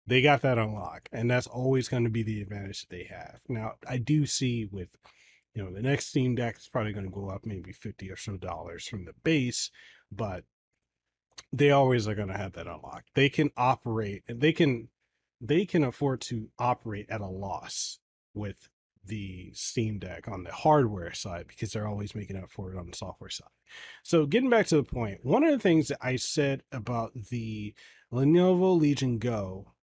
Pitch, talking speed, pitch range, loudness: 115 Hz, 195 wpm, 100-135 Hz, -29 LUFS